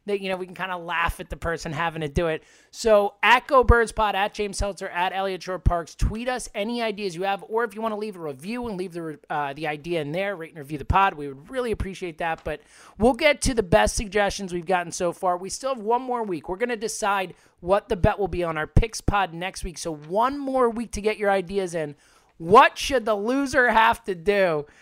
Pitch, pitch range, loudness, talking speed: 195 Hz, 170-220 Hz, -24 LUFS, 255 wpm